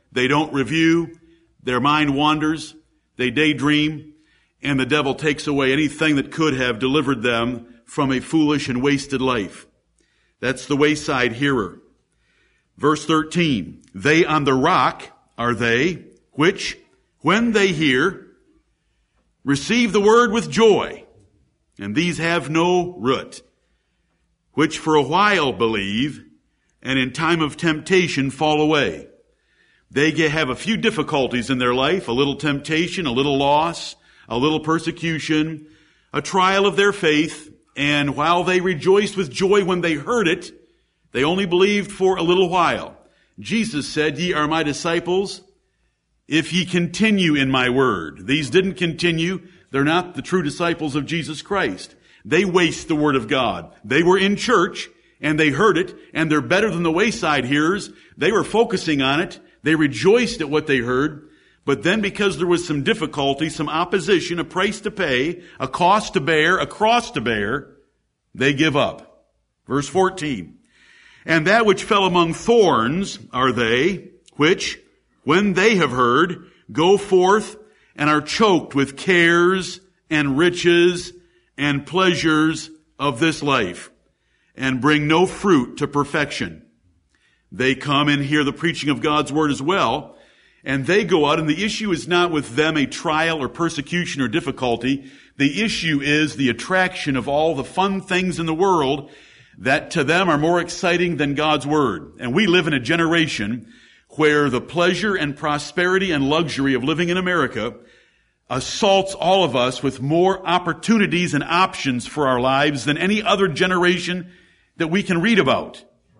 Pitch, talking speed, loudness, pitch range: 160 Hz, 155 wpm, -19 LUFS, 145-180 Hz